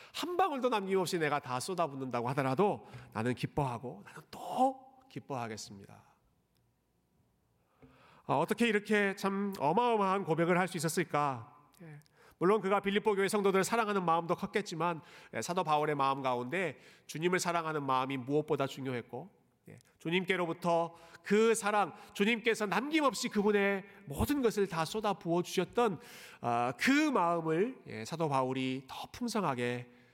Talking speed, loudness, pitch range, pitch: 310 characters per minute, -33 LUFS, 140-205 Hz, 175 Hz